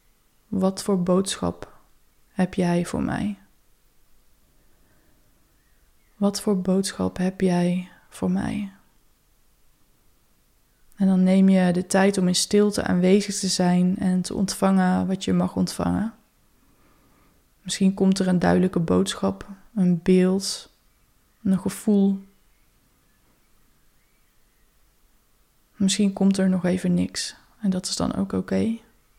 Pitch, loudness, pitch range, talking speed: 190 Hz, -23 LUFS, 180-195 Hz, 115 wpm